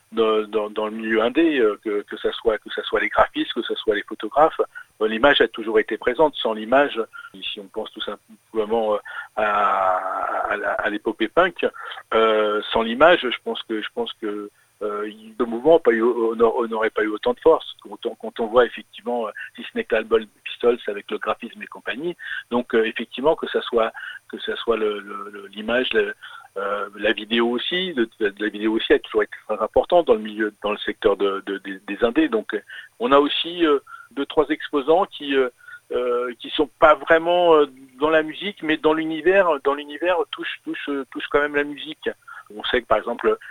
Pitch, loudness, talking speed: 150 Hz, -21 LUFS, 195 wpm